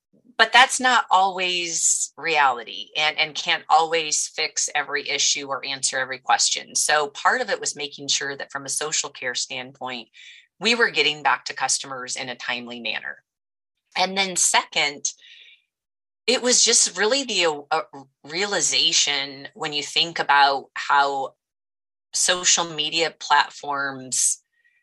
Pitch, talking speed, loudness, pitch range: 150 Hz, 135 wpm, -21 LUFS, 135-185 Hz